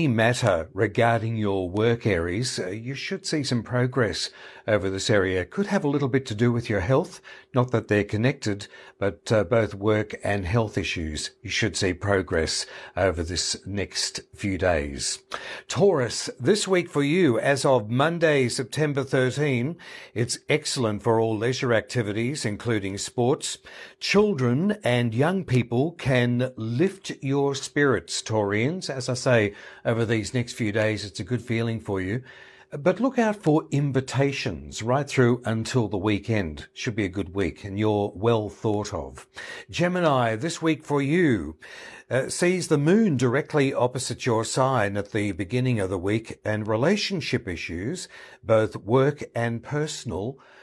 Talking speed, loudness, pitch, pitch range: 155 wpm, -25 LUFS, 120 Hz, 105-140 Hz